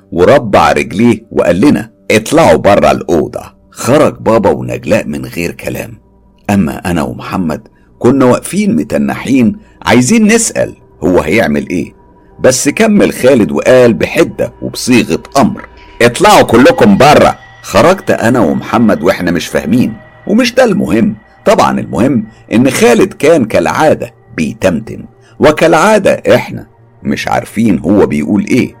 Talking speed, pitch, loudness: 115 wpm, 130 Hz, -9 LUFS